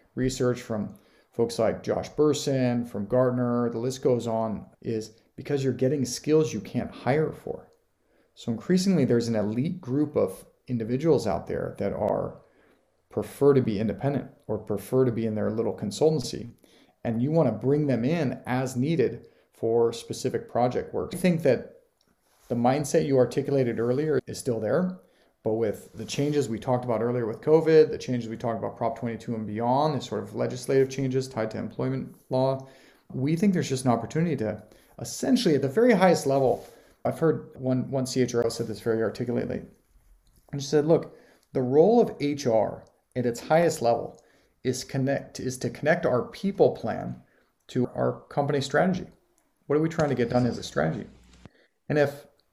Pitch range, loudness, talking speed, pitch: 115-145 Hz, -26 LUFS, 180 wpm, 130 Hz